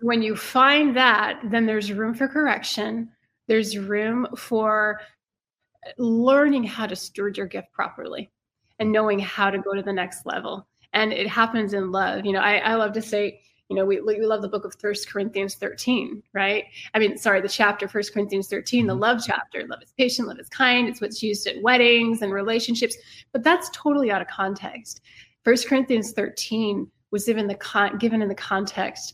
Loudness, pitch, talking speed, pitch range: -23 LUFS, 215 Hz, 190 wpm, 205-235 Hz